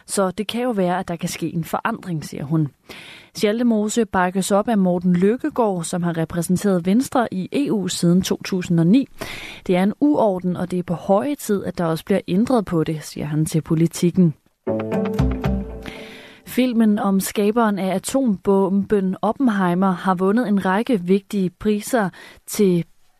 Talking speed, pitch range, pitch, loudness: 160 wpm, 175-210 Hz, 190 Hz, -20 LUFS